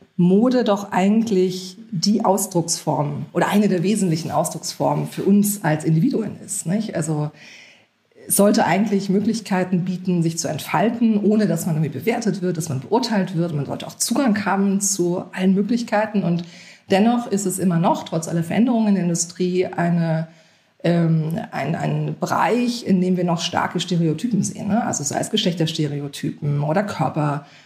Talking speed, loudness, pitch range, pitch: 160 wpm, -20 LUFS, 165-205 Hz, 185 Hz